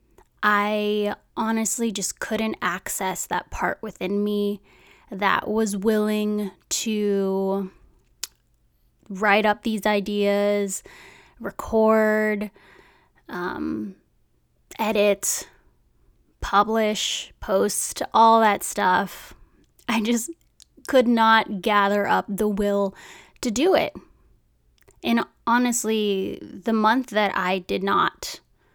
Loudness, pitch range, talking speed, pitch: -23 LUFS, 200-220 Hz, 90 wpm, 210 Hz